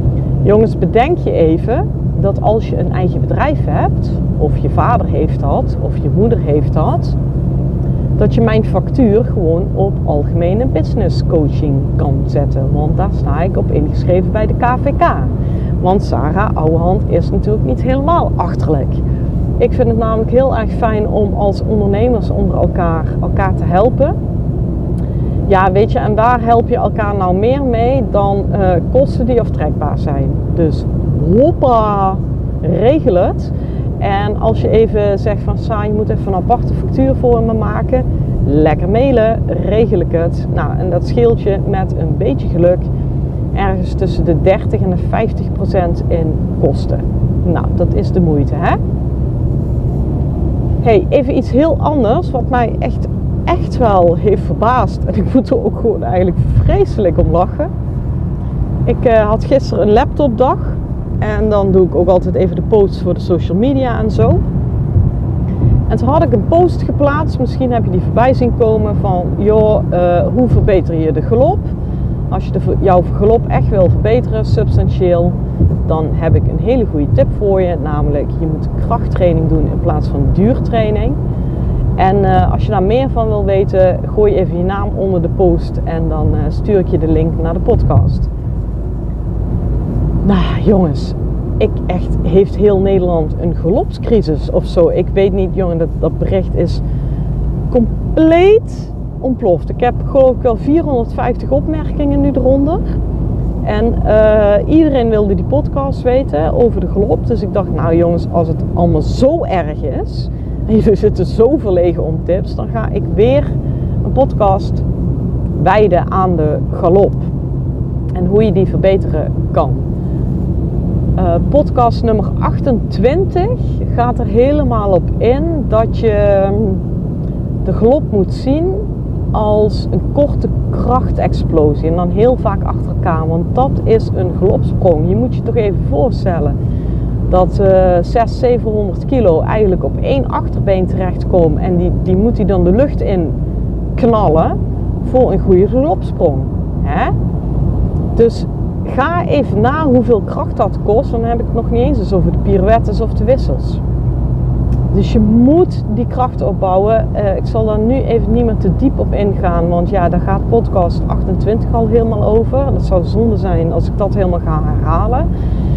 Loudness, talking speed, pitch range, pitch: -13 LUFS, 160 wpm, 110-175 Hz, 135 Hz